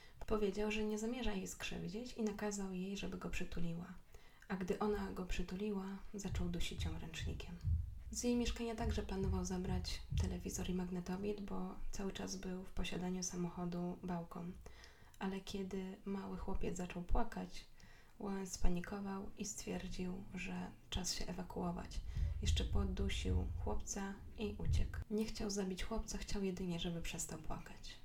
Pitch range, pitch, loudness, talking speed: 175-205 Hz, 185 Hz, -43 LUFS, 140 wpm